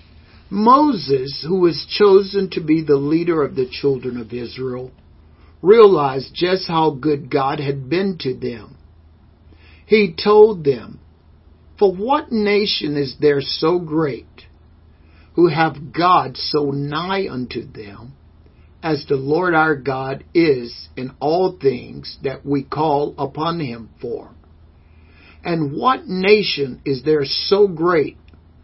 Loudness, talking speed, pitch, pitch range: -18 LUFS, 130 wpm, 140 Hz, 110-175 Hz